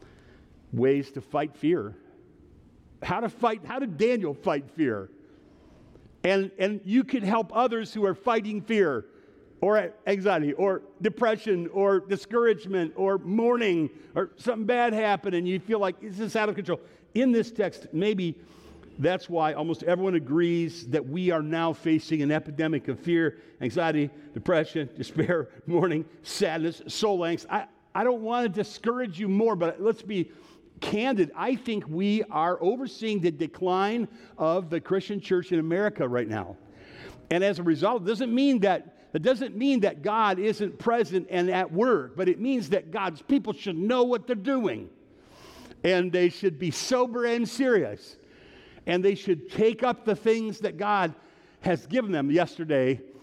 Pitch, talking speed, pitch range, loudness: 195 Hz, 160 wpm, 165-225 Hz, -27 LUFS